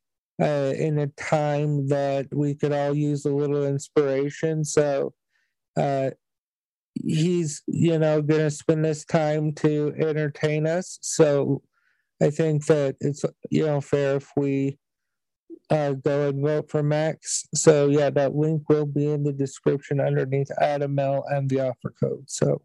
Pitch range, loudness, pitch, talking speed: 140-155 Hz, -24 LUFS, 145 Hz, 150 wpm